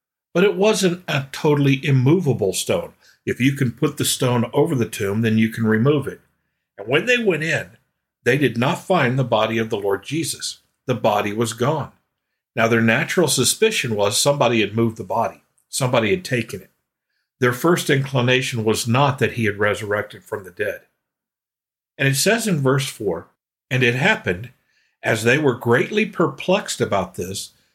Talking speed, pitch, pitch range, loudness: 175 wpm, 130 Hz, 115-155 Hz, -19 LUFS